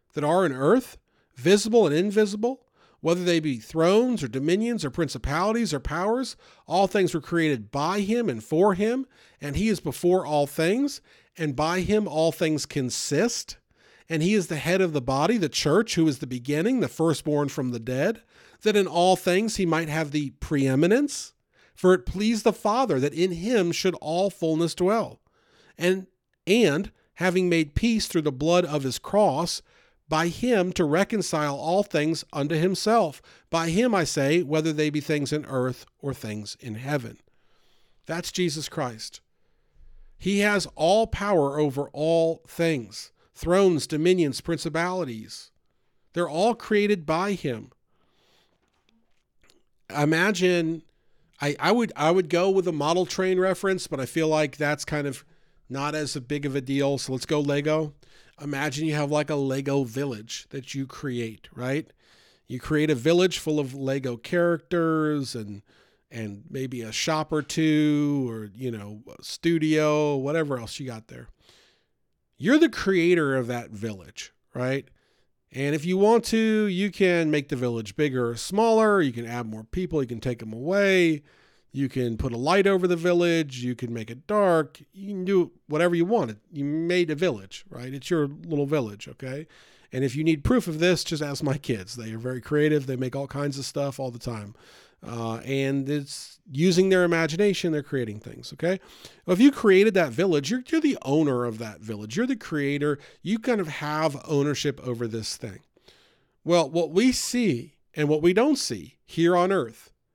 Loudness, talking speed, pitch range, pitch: -25 LUFS, 175 wpm, 135-185 Hz, 155 Hz